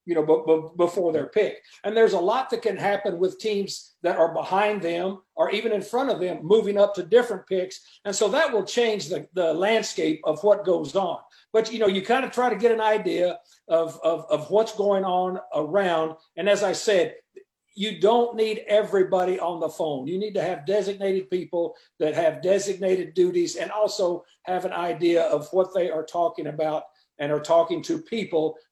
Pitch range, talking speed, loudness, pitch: 170-215 Hz, 205 wpm, -24 LUFS, 195 Hz